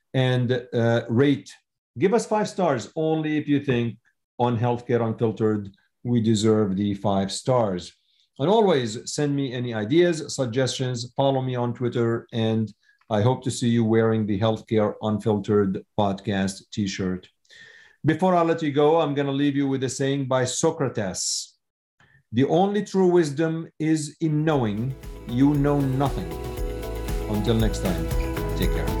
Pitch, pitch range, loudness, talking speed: 125 Hz, 110-145 Hz, -24 LUFS, 150 wpm